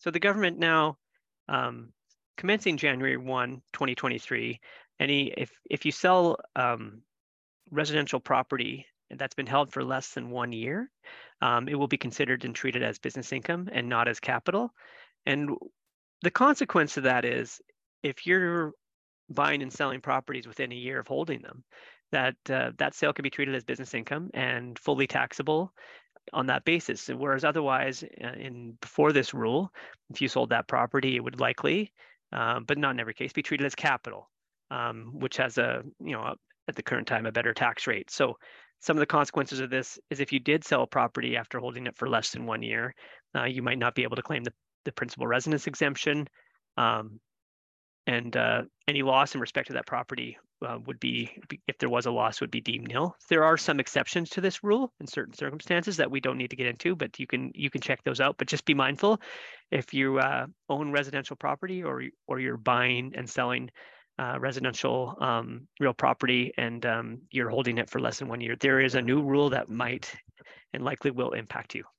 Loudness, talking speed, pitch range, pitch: -29 LUFS, 200 wpm, 125-155 Hz, 135 Hz